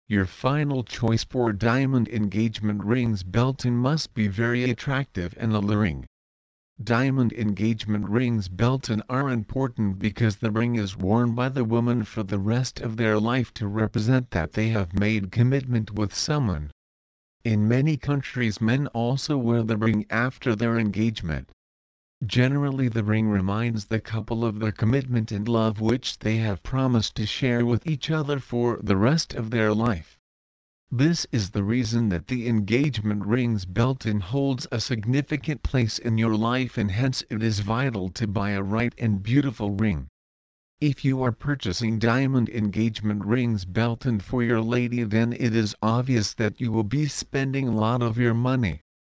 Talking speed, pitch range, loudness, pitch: 165 wpm, 105-125 Hz, -25 LUFS, 115 Hz